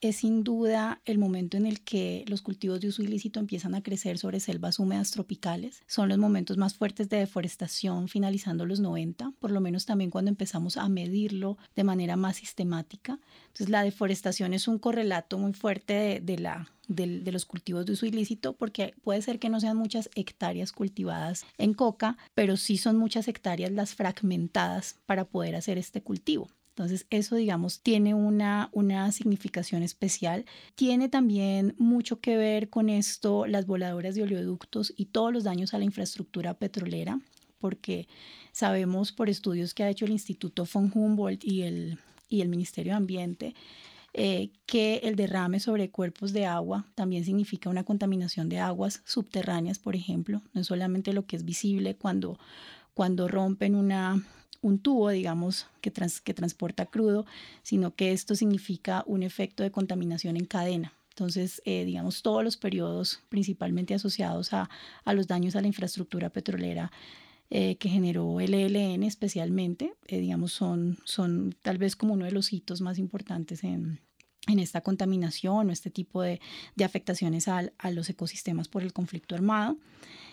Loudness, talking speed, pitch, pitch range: -30 LUFS, 170 wpm, 195 Hz, 180-210 Hz